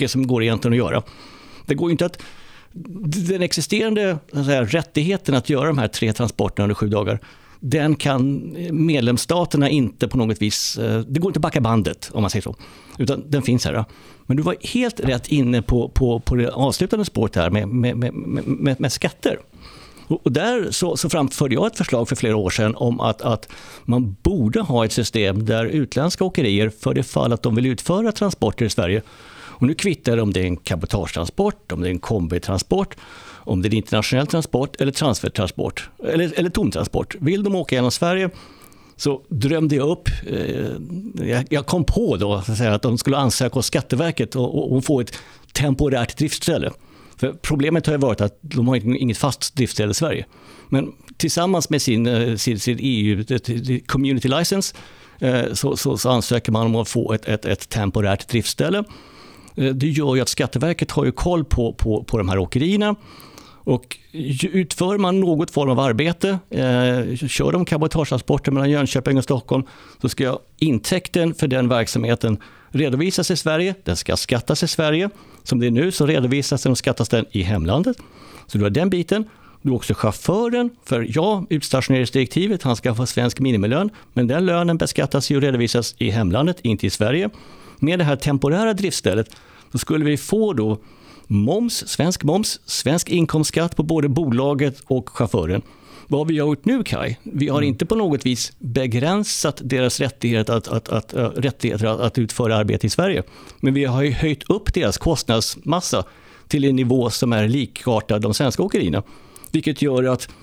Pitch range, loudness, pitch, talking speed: 115-155 Hz, -20 LUFS, 130 Hz, 180 wpm